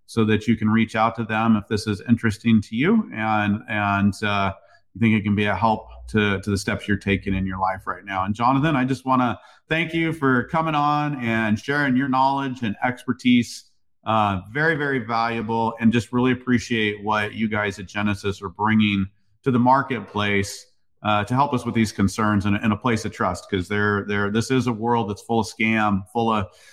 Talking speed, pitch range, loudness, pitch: 215 wpm, 105-125 Hz, -22 LUFS, 110 Hz